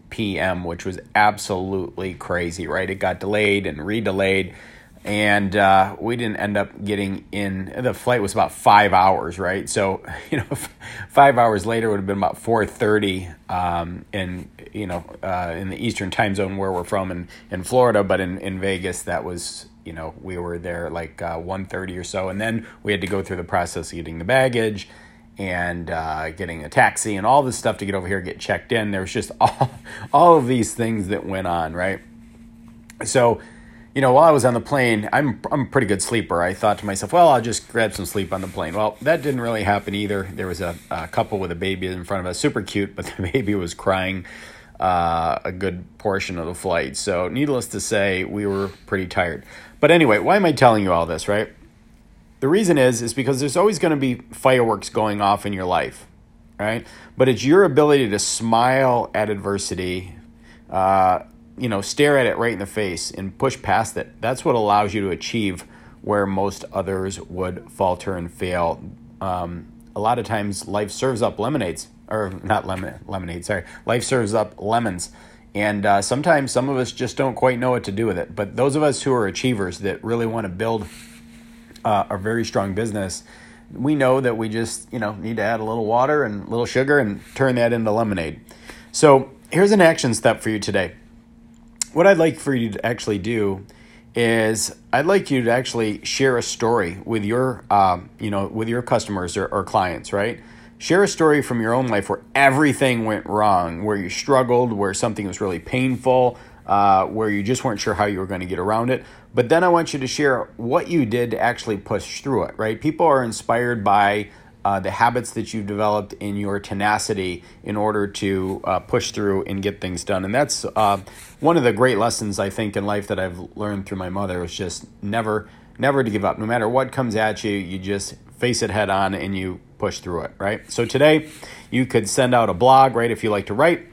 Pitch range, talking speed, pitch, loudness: 95-115 Hz, 215 wpm, 105 Hz, -21 LUFS